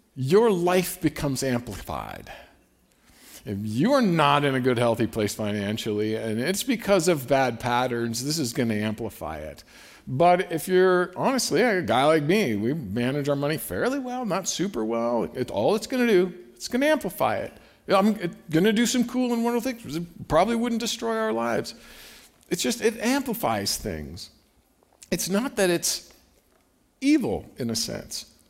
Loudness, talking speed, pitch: -24 LUFS, 170 wpm, 160 Hz